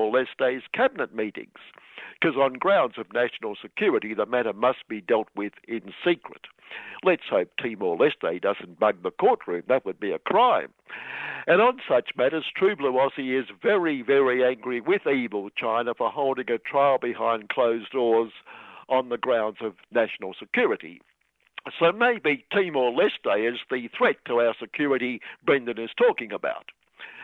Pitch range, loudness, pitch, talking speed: 115-140 Hz, -25 LUFS, 125 Hz, 150 wpm